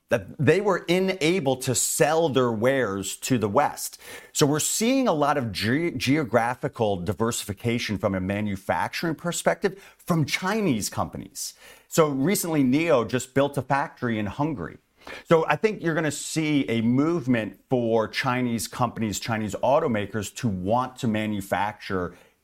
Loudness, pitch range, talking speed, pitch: -25 LUFS, 115-155 Hz, 140 wpm, 130 Hz